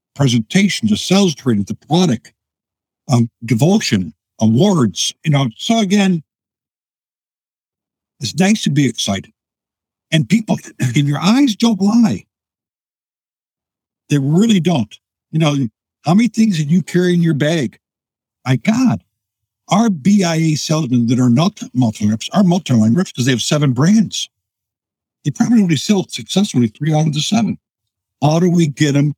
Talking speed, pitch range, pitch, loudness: 145 wpm, 120-195 Hz, 150 Hz, -15 LUFS